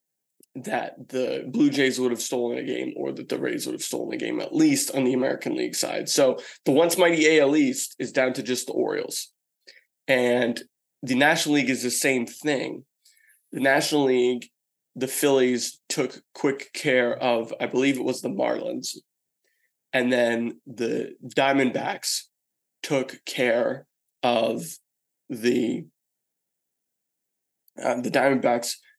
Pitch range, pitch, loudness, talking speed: 125-155 Hz, 130 Hz, -24 LUFS, 145 wpm